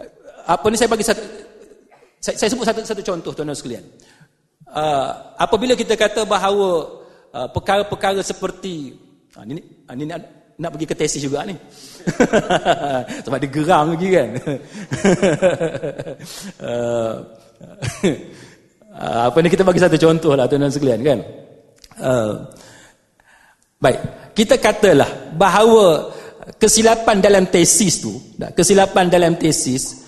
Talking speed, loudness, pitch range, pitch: 120 wpm, -16 LUFS, 150-210 Hz, 180 Hz